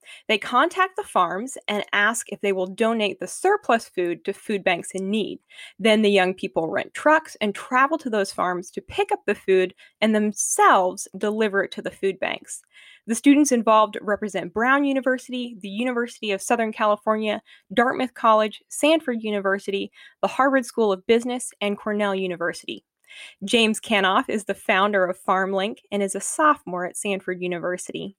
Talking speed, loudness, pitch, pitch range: 170 wpm, -22 LUFS, 215 Hz, 195-245 Hz